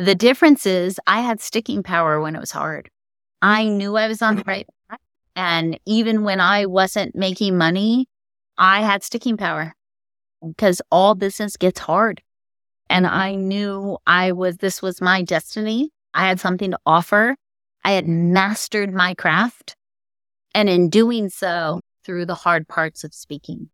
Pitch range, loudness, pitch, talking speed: 170-210 Hz, -18 LUFS, 190 Hz, 160 wpm